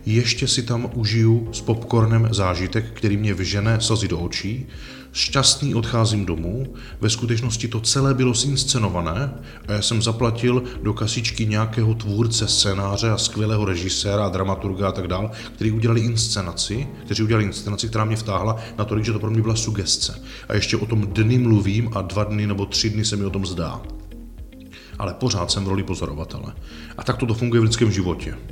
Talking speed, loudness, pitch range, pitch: 180 wpm, -21 LUFS, 100-115 Hz, 110 Hz